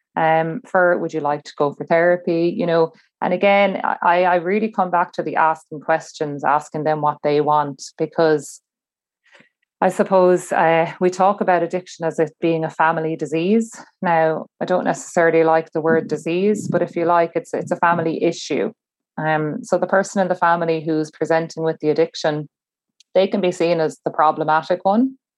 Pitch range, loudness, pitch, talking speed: 160-180 Hz, -19 LUFS, 165 Hz, 185 wpm